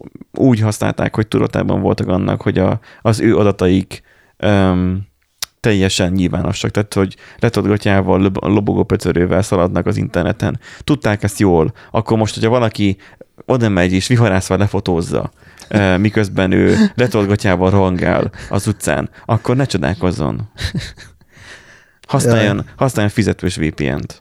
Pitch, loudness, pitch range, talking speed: 100 Hz, -16 LUFS, 90-110 Hz, 120 wpm